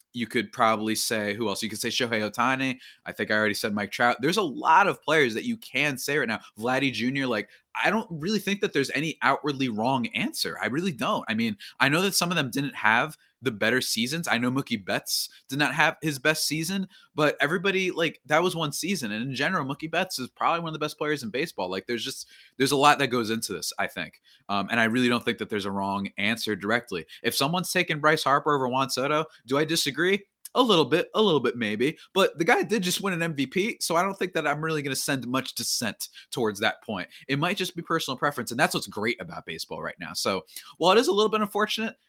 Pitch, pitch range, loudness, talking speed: 145 Hz, 120-175 Hz, -26 LUFS, 250 wpm